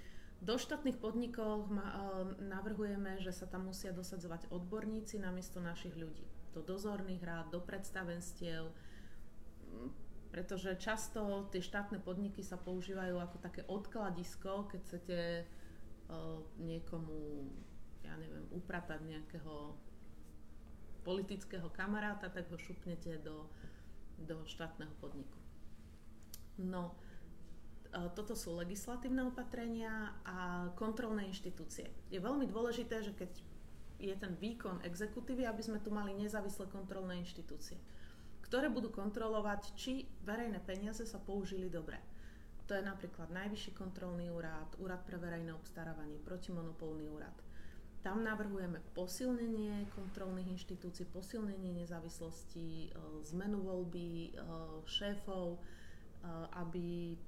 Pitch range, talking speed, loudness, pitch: 160-205 Hz, 110 wpm, -45 LUFS, 180 Hz